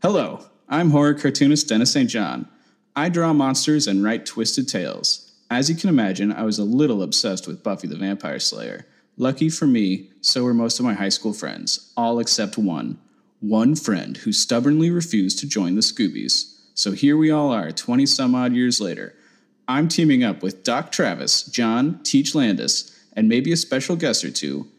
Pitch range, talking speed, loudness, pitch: 110-155 Hz, 185 wpm, -20 LUFS, 130 Hz